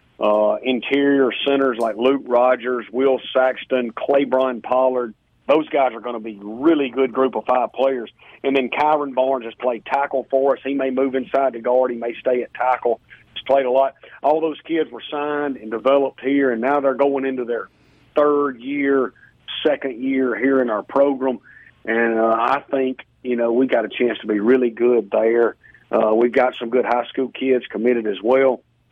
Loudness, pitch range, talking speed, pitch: -19 LUFS, 120-135 Hz, 195 wpm, 130 Hz